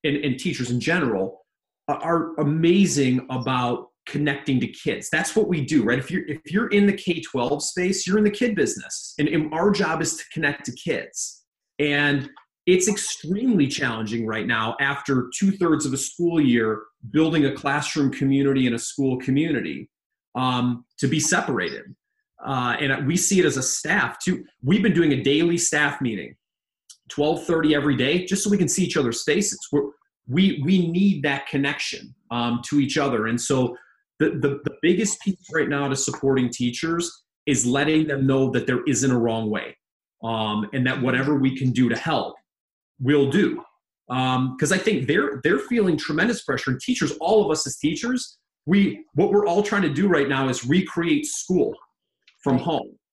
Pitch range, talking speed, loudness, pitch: 130-180 Hz, 180 wpm, -22 LUFS, 145 Hz